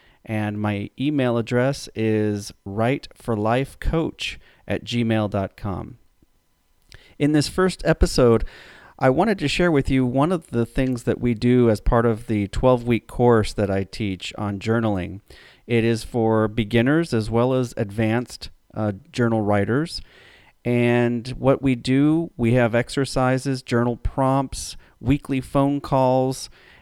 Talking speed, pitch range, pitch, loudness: 135 wpm, 110-130 Hz, 120 Hz, -22 LUFS